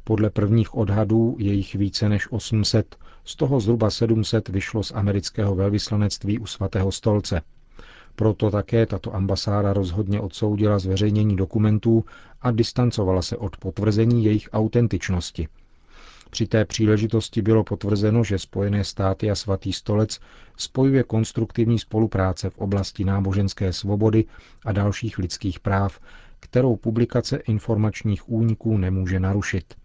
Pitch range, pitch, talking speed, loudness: 95-110 Hz, 105 Hz, 125 wpm, -22 LUFS